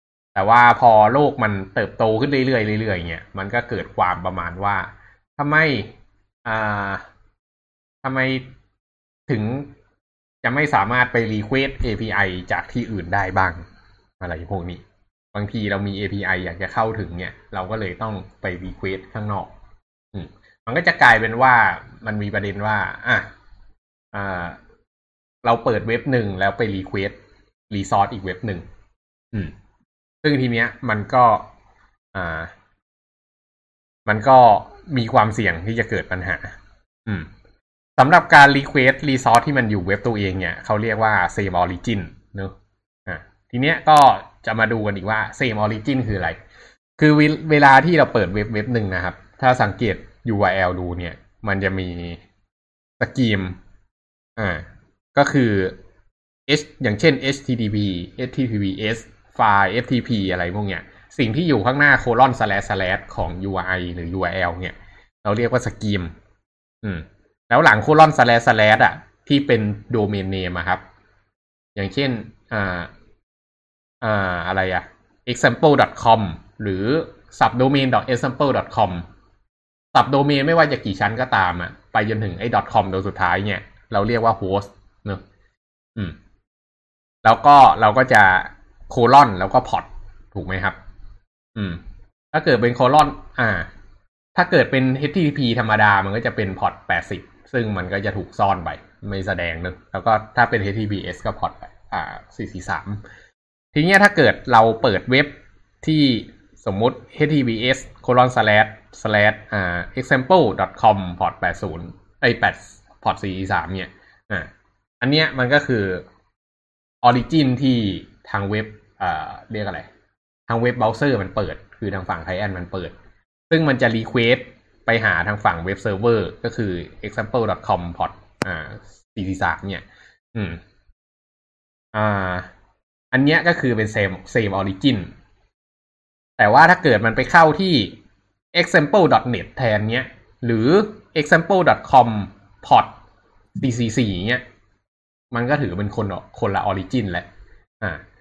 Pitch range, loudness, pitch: 95-120 Hz, -18 LUFS, 105 Hz